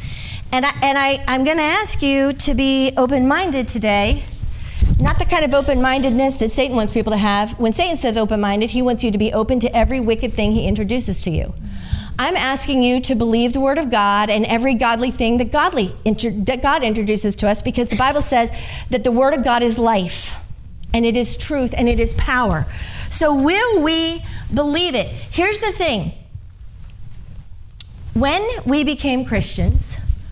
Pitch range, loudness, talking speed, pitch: 220-275 Hz, -17 LUFS, 190 wpm, 250 Hz